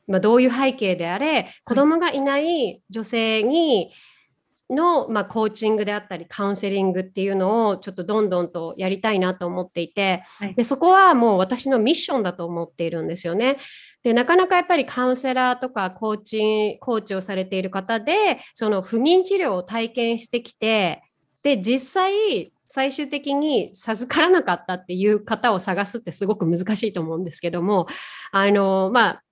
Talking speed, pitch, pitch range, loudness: 370 characters per minute, 220 Hz, 190-260 Hz, -21 LUFS